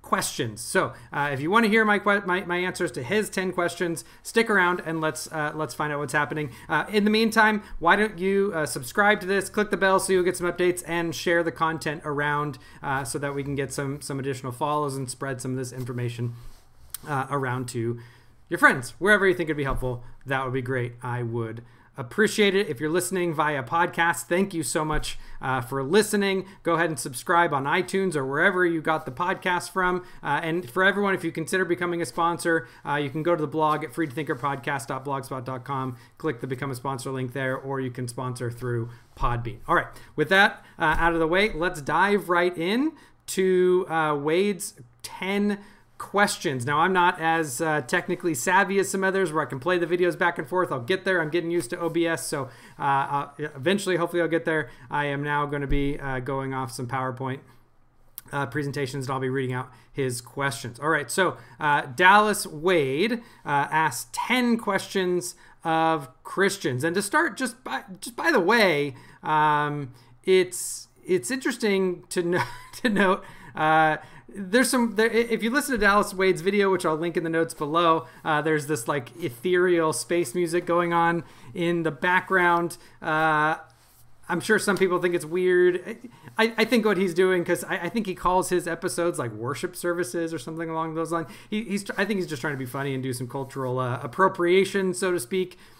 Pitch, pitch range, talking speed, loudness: 165 Hz, 140-185 Hz, 200 wpm, -25 LUFS